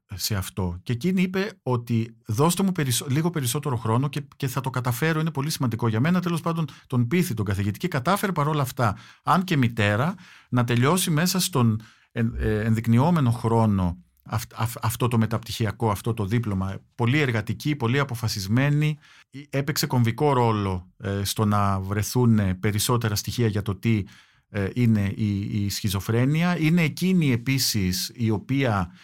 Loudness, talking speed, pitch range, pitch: -24 LUFS, 150 wpm, 110-145 Hz, 120 Hz